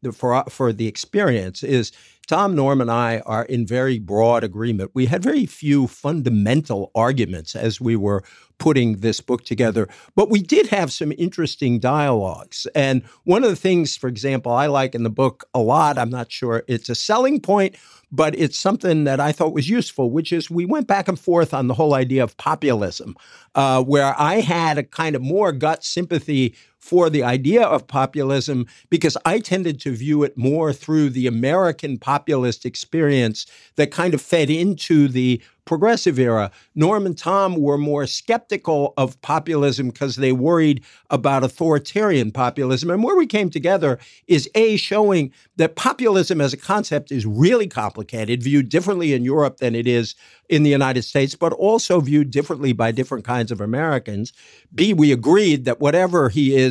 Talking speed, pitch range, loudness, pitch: 180 wpm, 125-165 Hz, -19 LUFS, 140 Hz